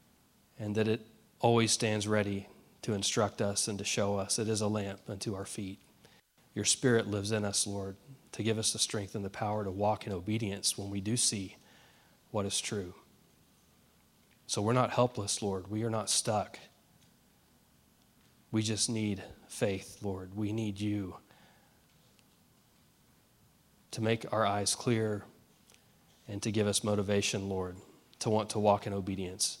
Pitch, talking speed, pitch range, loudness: 105 Hz, 160 wpm, 100-110 Hz, -33 LUFS